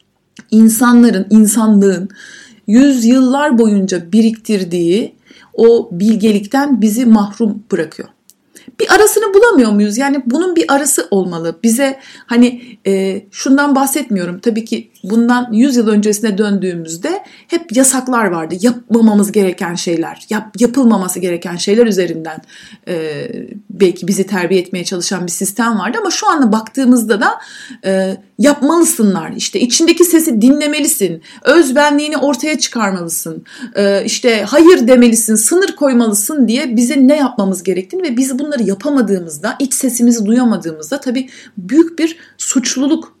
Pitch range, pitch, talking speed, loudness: 200-275 Hz, 230 Hz, 120 wpm, -12 LUFS